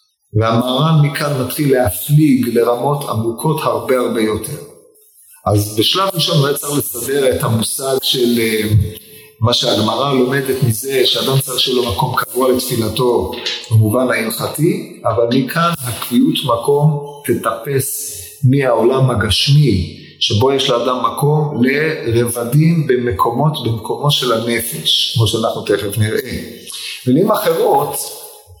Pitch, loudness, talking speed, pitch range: 130 Hz, -15 LUFS, 115 wpm, 115-150 Hz